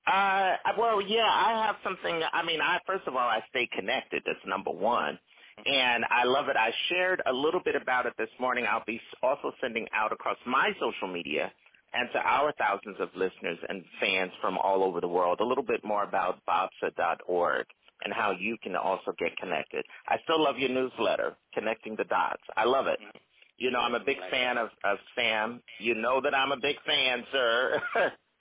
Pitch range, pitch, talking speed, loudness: 110-180 Hz, 125 Hz, 200 wpm, -29 LUFS